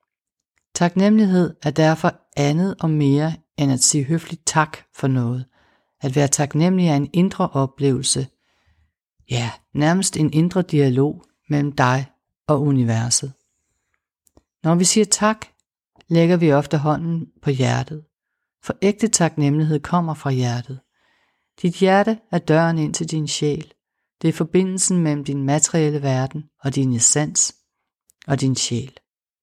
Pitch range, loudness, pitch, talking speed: 135-170 Hz, -19 LUFS, 150 Hz, 135 wpm